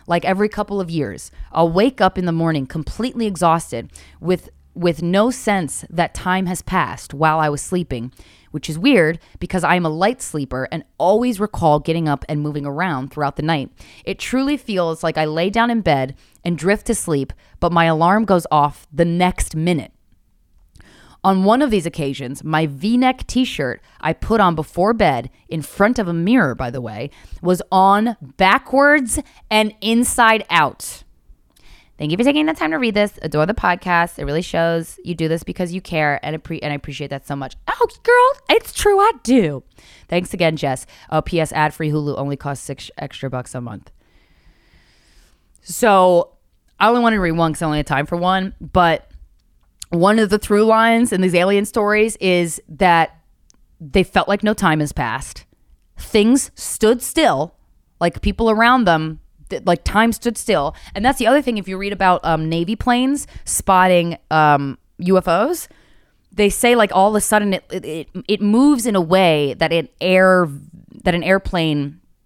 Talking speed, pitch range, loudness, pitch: 185 wpm, 150-210 Hz, -17 LUFS, 175 Hz